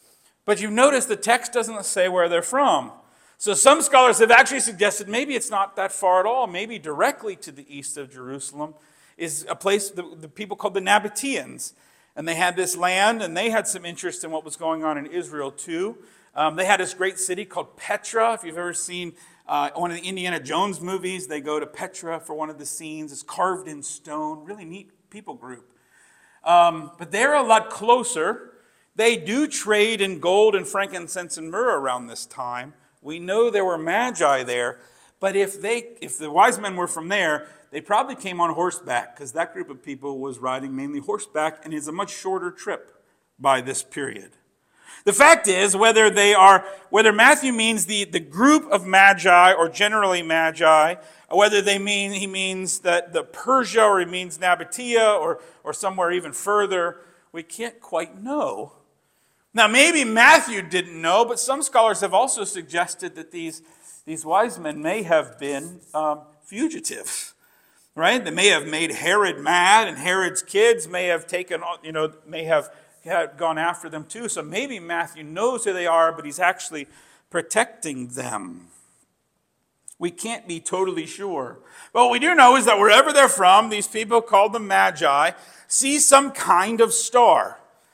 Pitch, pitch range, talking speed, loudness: 185 Hz, 165-220 Hz, 185 wpm, -20 LUFS